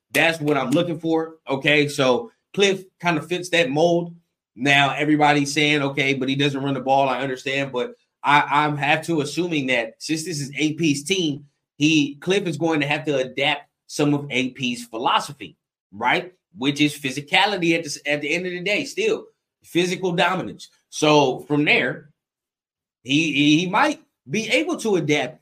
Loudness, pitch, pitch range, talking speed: -21 LUFS, 150 Hz, 140-170 Hz, 175 wpm